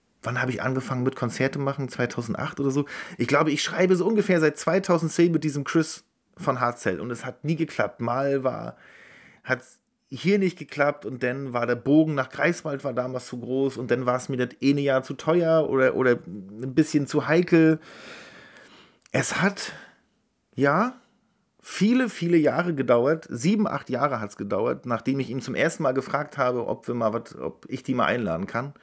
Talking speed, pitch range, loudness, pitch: 195 wpm, 130-160 Hz, -25 LUFS, 140 Hz